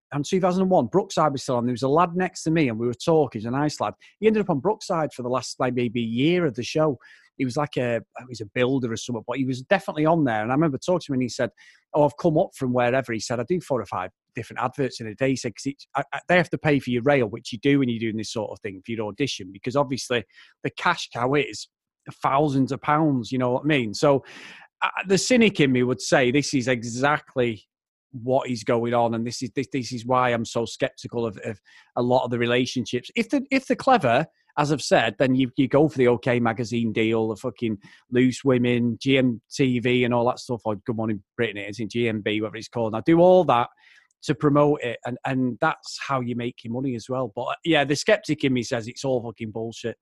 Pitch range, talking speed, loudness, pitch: 120-145 Hz, 255 wpm, -24 LUFS, 130 Hz